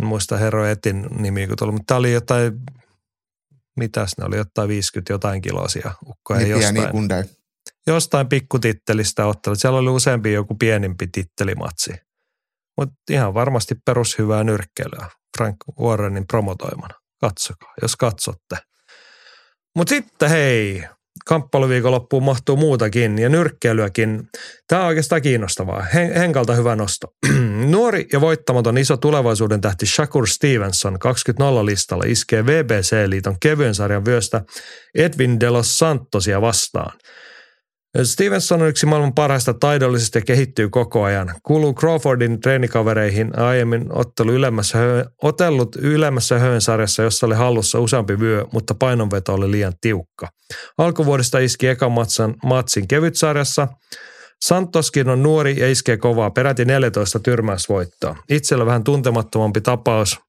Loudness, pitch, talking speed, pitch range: -18 LUFS, 120 Hz, 120 wpm, 110-135 Hz